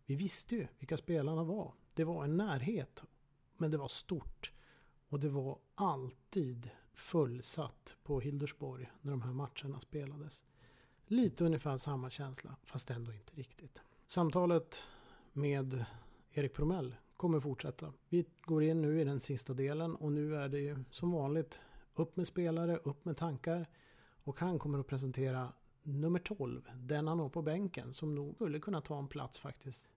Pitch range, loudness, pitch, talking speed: 135-165 Hz, -39 LUFS, 145 Hz, 160 wpm